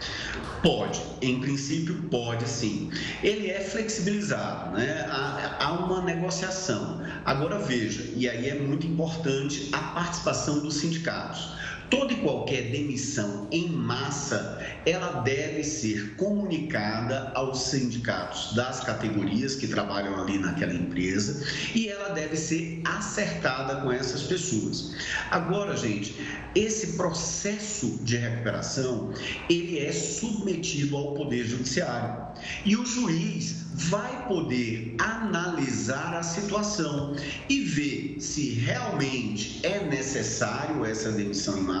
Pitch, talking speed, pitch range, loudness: 145 Hz, 115 wpm, 125-175 Hz, -28 LUFS